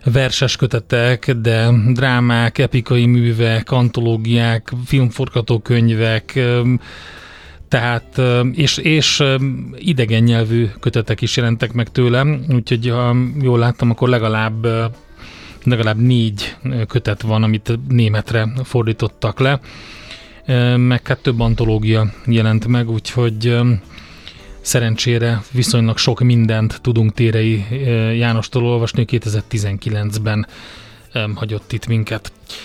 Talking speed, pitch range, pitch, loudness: 95 wpm, 110-125 Hz, 120 Hz, -16 LUFS